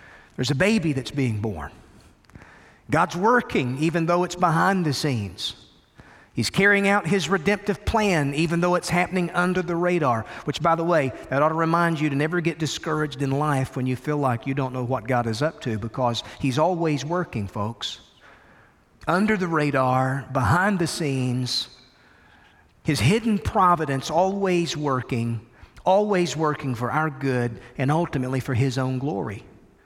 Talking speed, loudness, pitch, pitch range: 165 wpm, -23 LUFS, 150 Hz, 130-175 Hz